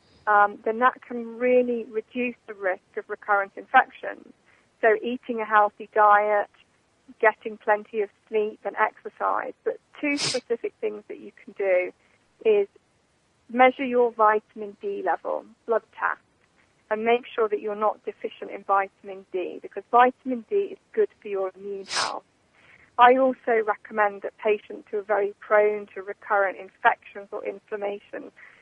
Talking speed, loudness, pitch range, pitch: 150 wpm, -25 LUFS, 205-250 Hz, 220 Hz